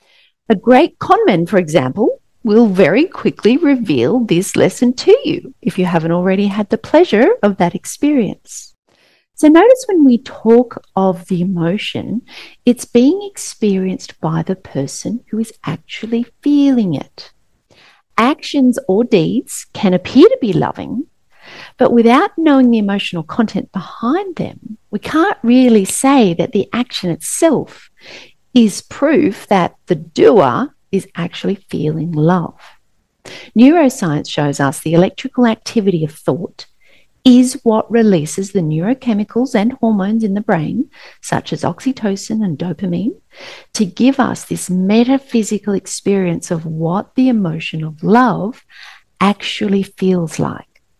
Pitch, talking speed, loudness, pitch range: 220 Hz, 135 wpm, -14 LUFS, 185-260 Hz